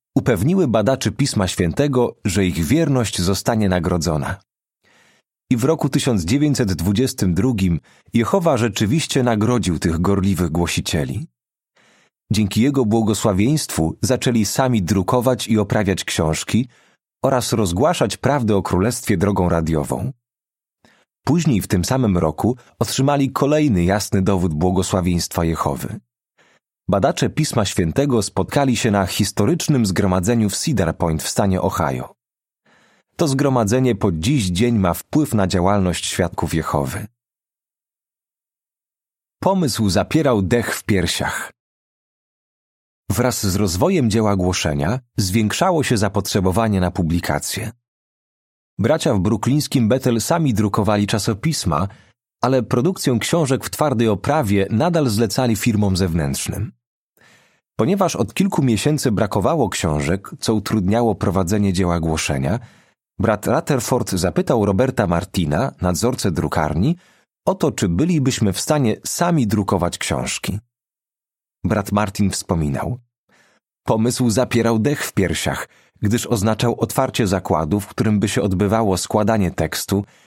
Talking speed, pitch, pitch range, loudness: 110 wpm, 110 Hz, 95-125 Hz, -19 LUFS